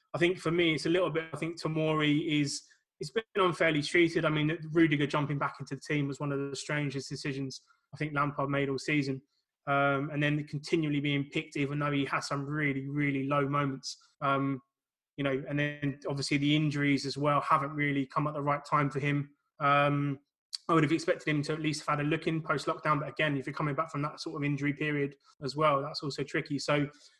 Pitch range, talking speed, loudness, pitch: 140-155 Hz, 230 wpm, -31 LUFS, 145 Hz